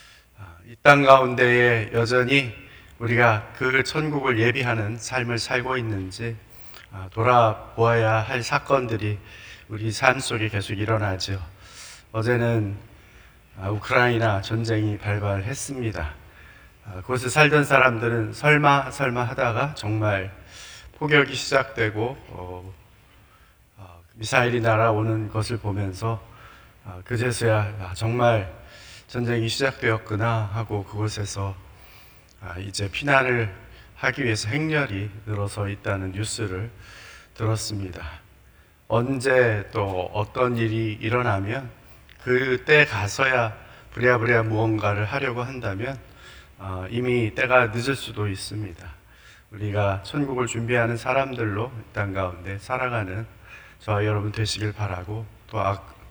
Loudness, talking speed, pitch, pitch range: -23 LUFS, 245 characters per minute, 110 Hz, 100-125 Hz